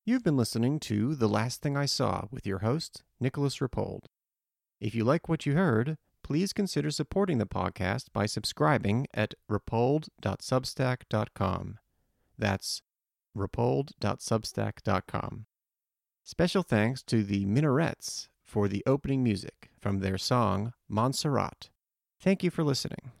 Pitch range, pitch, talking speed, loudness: 105-145 Hz, 120 Hz, 125 wpm, -30 LUFS